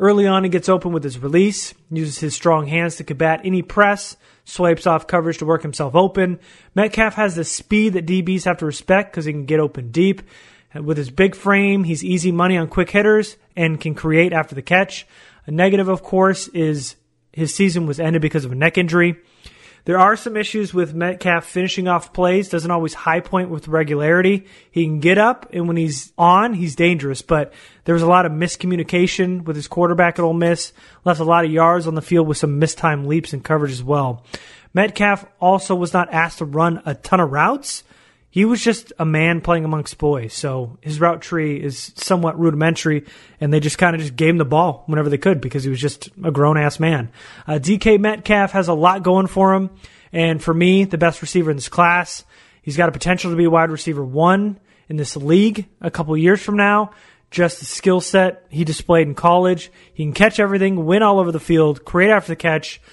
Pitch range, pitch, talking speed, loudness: 155-185 Hz, 170 Hz, 215 wpm, -17 LUFS